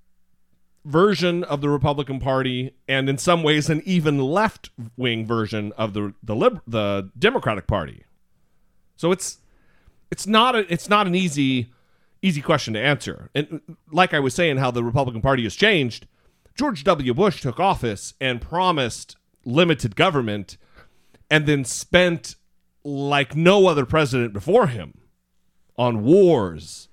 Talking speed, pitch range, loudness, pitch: 145 wpm, 120-175 Hz, -21 LUFS, 140 Hz